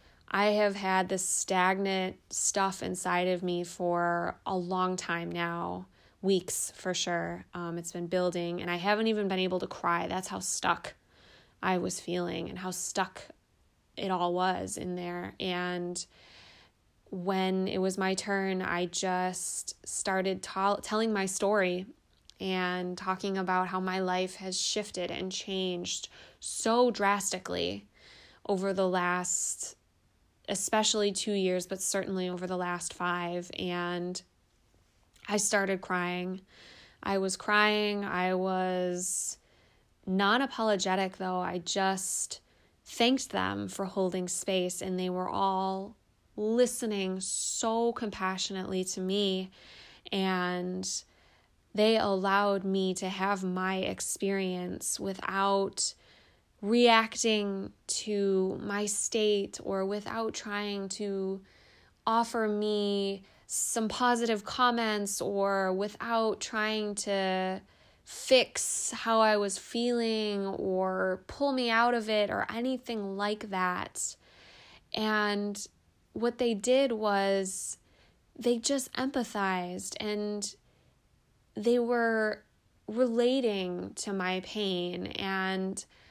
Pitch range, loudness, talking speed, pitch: 185-210 Hz, -31 LUFS, 115 wpm, 190 Hz